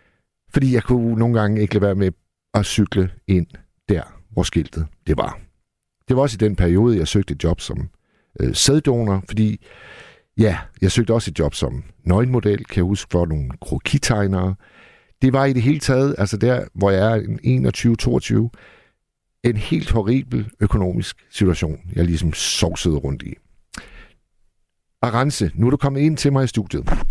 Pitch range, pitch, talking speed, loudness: 90-120 Hz, 105 Hz, 170 wpm, -19 LUFS